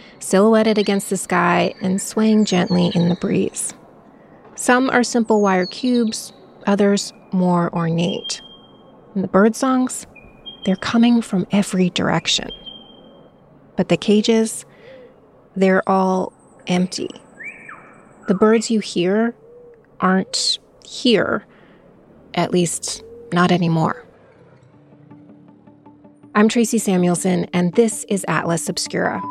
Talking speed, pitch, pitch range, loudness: 105 wpm, 195 Hz, 180-225 Hz, -18 LUFS